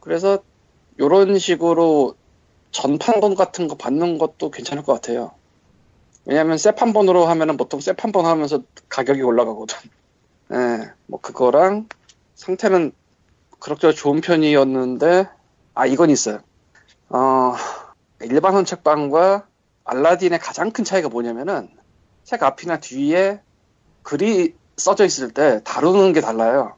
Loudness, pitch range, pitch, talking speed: -18 LUFS, 140-195 Hz, 170 Hz, 265 characters per minute